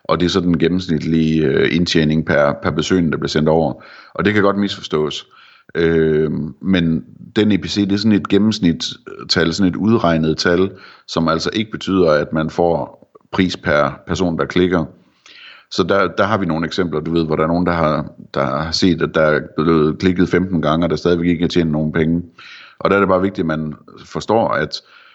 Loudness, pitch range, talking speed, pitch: -17 LUFS, 80-95 Hz, 210 wpm, 85 Hz